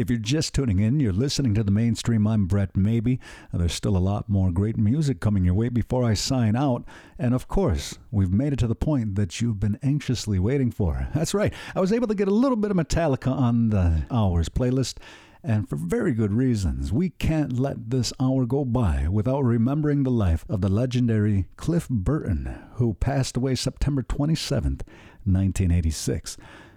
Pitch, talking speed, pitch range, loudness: 115 Hz, 190 wpm, 100-135 Hz, -24 LUFS